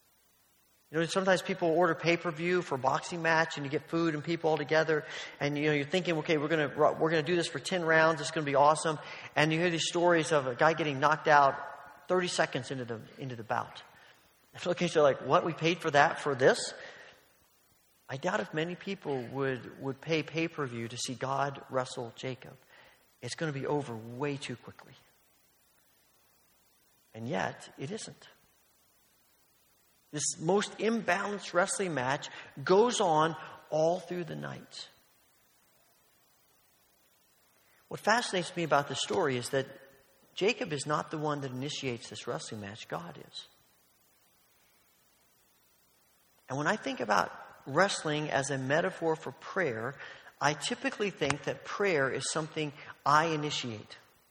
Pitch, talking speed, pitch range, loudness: 155 Hz, 160 wpm, 135-170 Hz, -31 LUFS